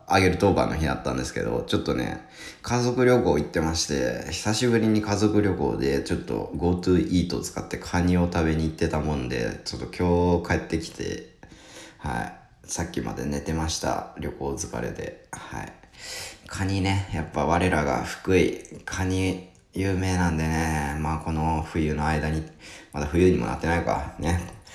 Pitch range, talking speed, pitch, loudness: 80-95 Hz, 330 characters per minute, 85 Hz, -25 LUFS